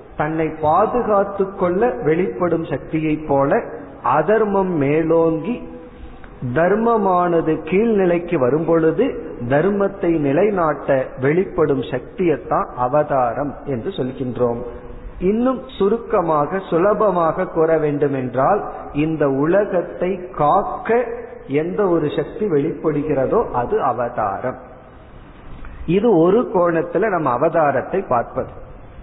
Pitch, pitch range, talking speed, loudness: 160 Hz, 145-195 Hz, 85 wpm, -18 LUFS